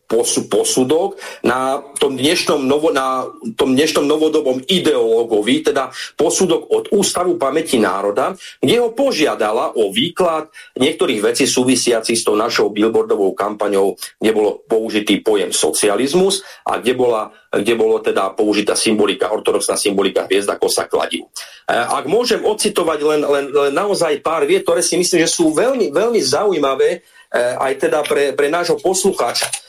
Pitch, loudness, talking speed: 235 Hz, -16 LUFS, 145 wpm